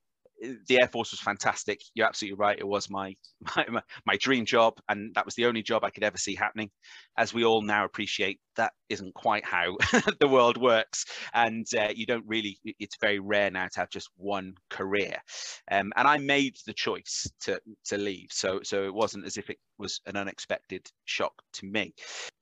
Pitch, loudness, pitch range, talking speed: 105 Hz, -28 LUFS, 100-115 Hz, 200 wpm